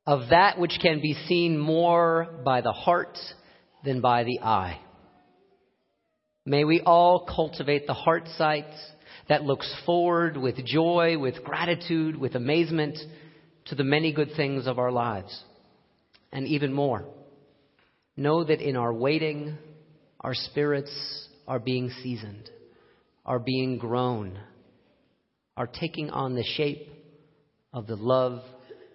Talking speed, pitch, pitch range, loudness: 130 wpm, 145 Hz, 130-160 Hz, -26 LUFS